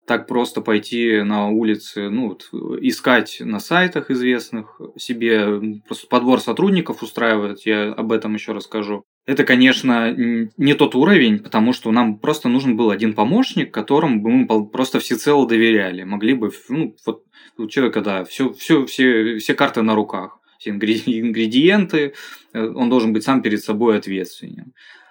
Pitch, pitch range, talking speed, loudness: 115 Hz, 110-140 Hz, 150 wpm, -18 LUFS